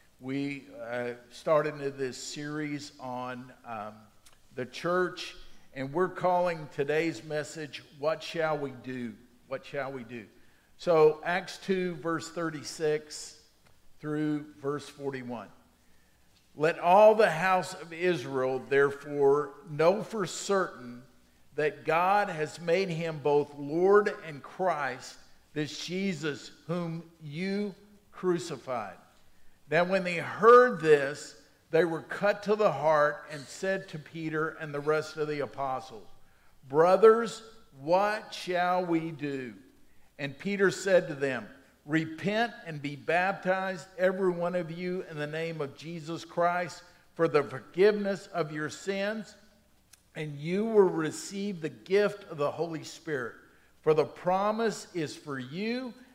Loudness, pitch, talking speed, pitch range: -29 LUFS, 160 Hz, 130 wpm, 145-185 Hz